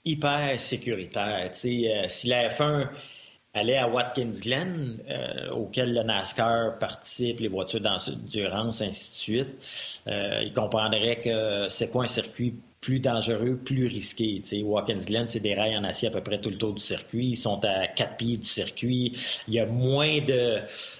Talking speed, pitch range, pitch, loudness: 185 wpm, 110-125 Hz, 115 Hz, -27 LUFS